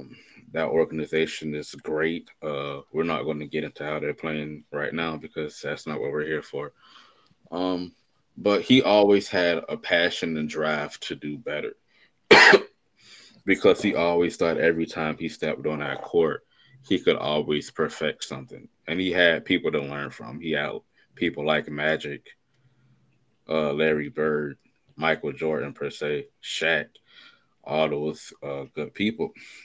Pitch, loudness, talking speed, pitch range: 80 Hz, -25 LUFS, 155 wpm, 75-100 Hz